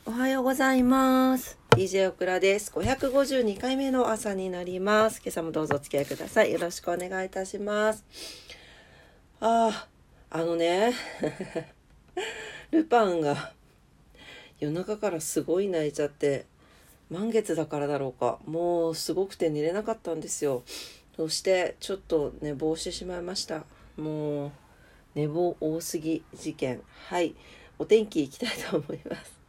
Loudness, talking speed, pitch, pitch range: -28 LUFS, 280 characters per minute, 175 Hz, 155-220 Hz